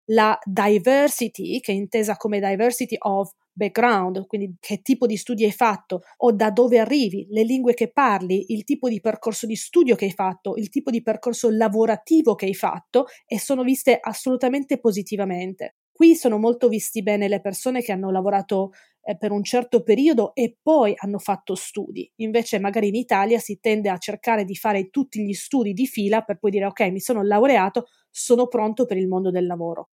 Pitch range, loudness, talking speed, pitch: 200-240 Hz, -21 LUFS, 190 wpm, 220 Hz